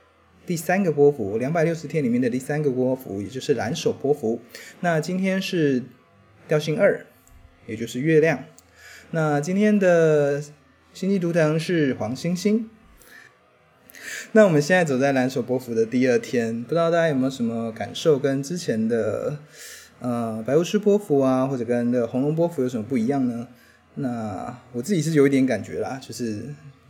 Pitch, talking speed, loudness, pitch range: 145 Hz, 255 characters per minute, -22 LUFS, 125-170 Hz